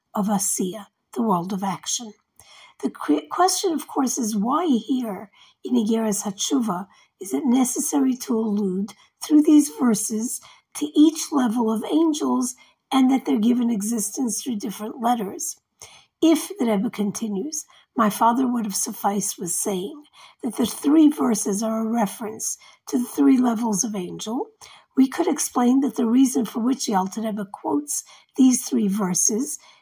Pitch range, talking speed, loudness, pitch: 210-275 Hz, 150 wpm, -22 LUFS, 235 Hz